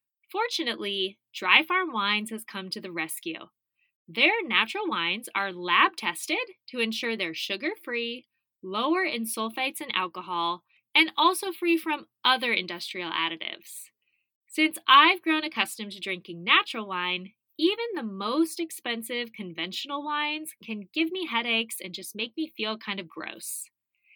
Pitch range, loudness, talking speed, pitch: 195-315 Hz, -26 LUFS, 145 wpm, 230 Hz